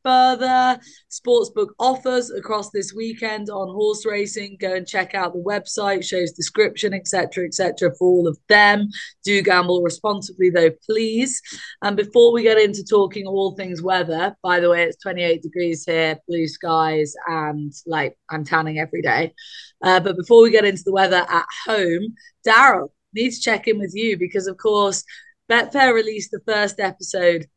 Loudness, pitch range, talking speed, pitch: -19 LUFS, 180-225 Hz, 170 wpm, 200 Hz